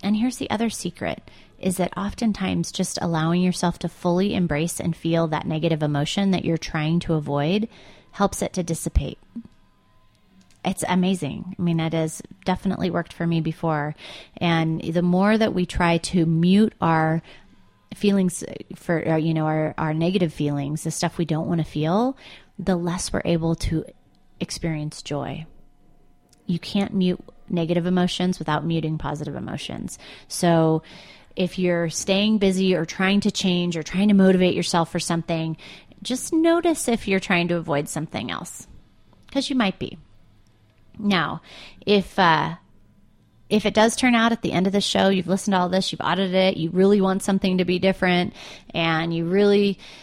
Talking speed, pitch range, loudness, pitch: 170 wpm, 160-195 Hz, -22 LUFS, 175 Hz